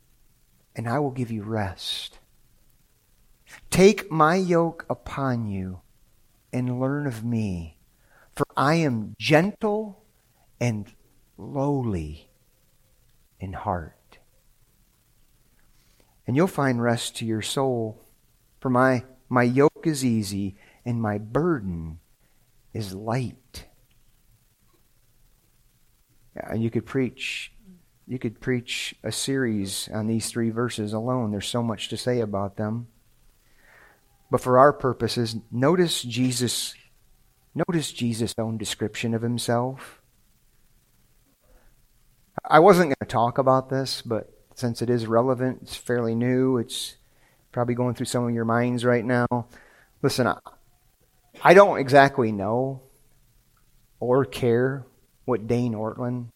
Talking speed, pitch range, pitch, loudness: 120 wpm, 110-130 Hz, 120 Hz, -24 LUFS